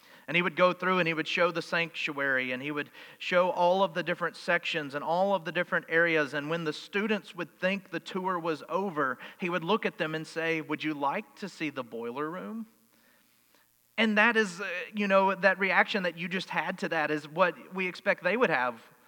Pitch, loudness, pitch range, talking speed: 175 Hz, -29 LUFS, 155-190 Hz, 225 wpm